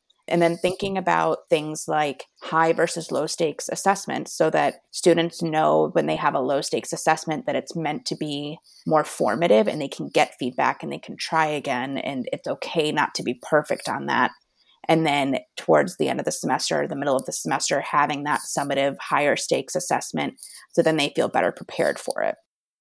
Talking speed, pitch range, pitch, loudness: 195 wpm, 150-170 Hz, 160 Hz, -23 LUFS